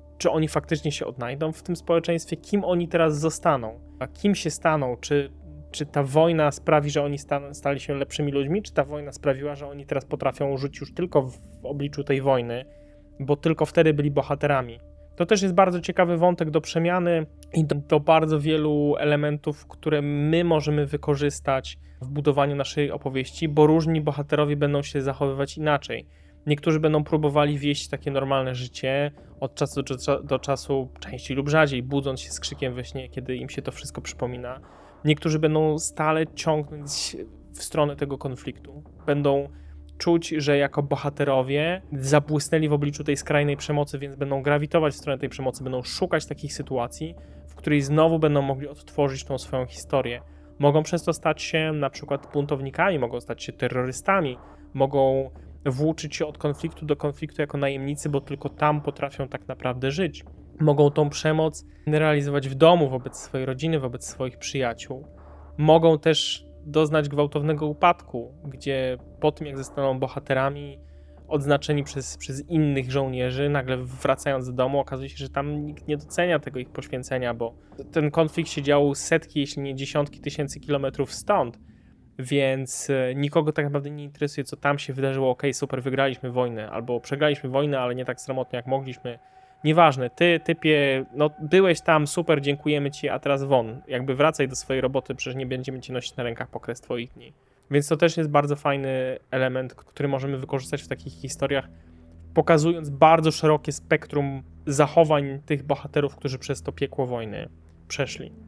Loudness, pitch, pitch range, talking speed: -24 LUFS, 145 Hz, 130-150 Hz, 165 wpm